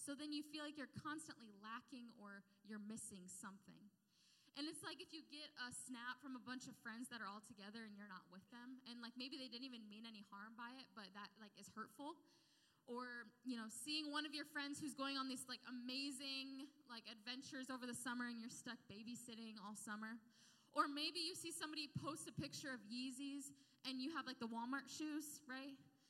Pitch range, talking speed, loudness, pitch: 225-280 Hz, 215 wpm, -51 LUFS, 250 Hz